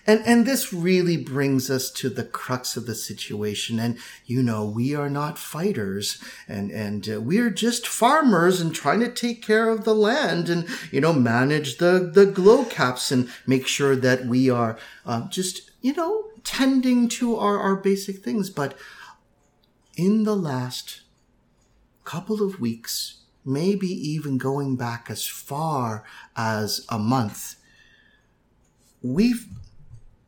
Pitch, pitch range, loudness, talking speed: 145 Hz, 125-205 Hz, -23 LUFS, 145 wpm